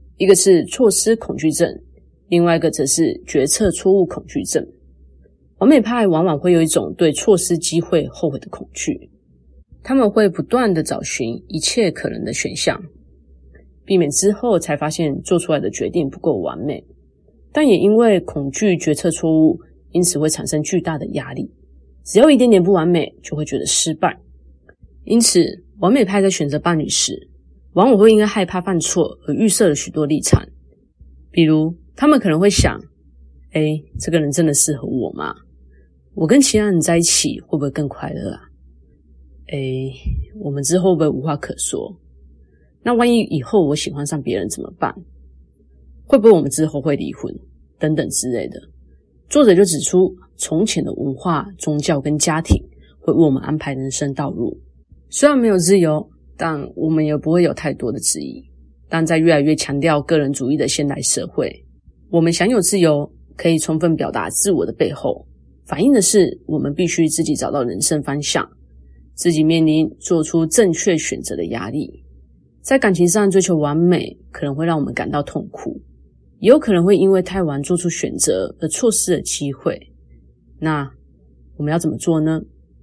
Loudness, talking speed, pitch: -17 LUFS, 260 characters per minute, 155 Hz